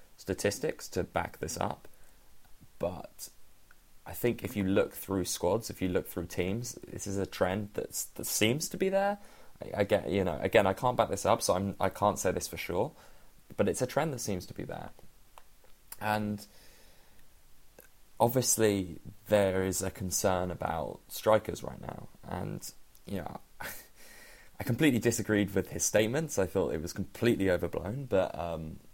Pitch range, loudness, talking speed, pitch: 95-115 Hz, -31 LUFS, 170 wpm, 105 Hz